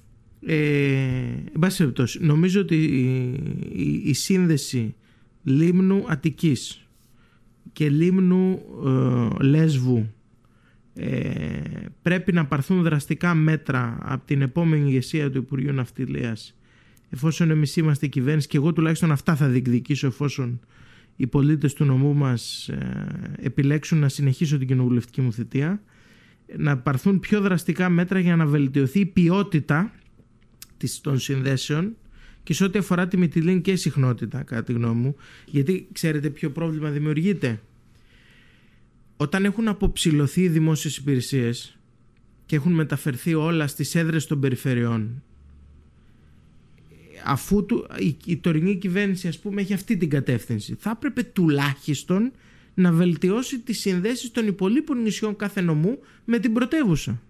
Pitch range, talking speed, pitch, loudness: 125-180 Hz, 125 wpm, 150 Hz, -23 LUFS